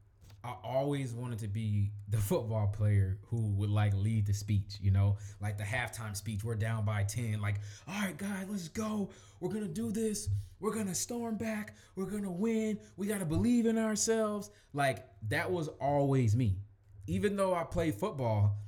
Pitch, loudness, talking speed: 115 Hz, -34 LUFS, 180 wpm